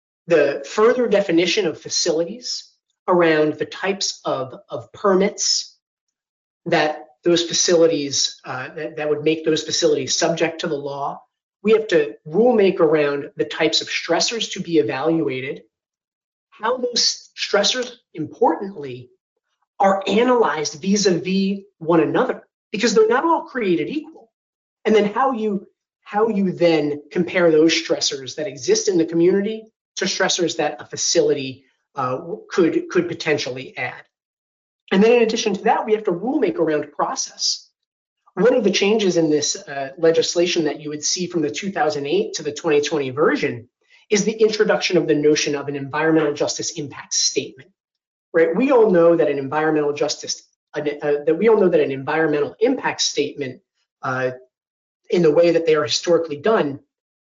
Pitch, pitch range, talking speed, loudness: 170 Hz, 150-215 Hz, 155 wpm, -19 LUFS